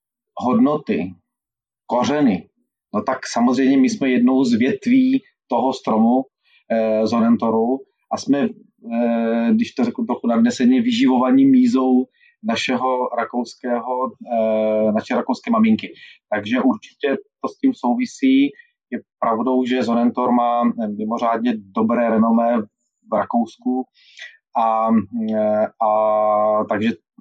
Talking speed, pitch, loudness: 110 wpm, 125 Hz, -19 LUFS